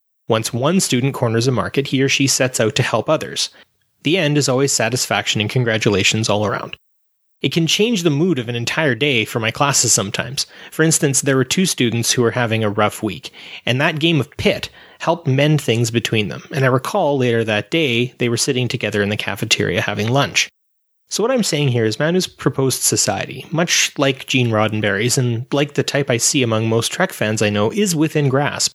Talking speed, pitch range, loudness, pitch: 210 wpm, 115-145 Hz, -17 LUFS, 130 Hz